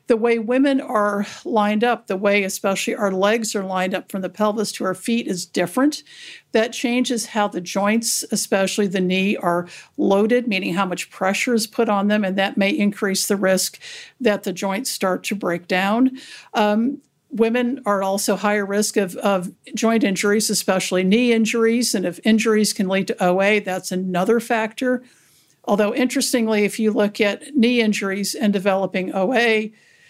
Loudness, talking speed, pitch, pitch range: -20 LUFS, 175 wpm, 210 Hz, 195-235 Hz